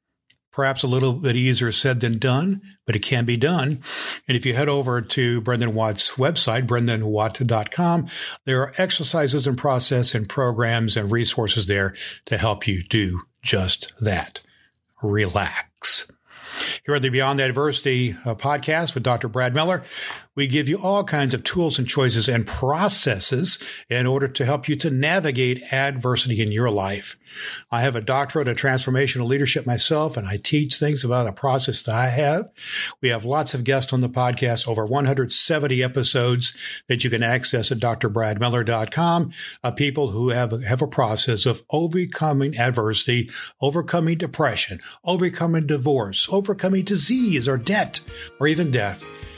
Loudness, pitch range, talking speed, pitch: -21 LUFS, 120-145 Hz, 155 wpm, 130 Hz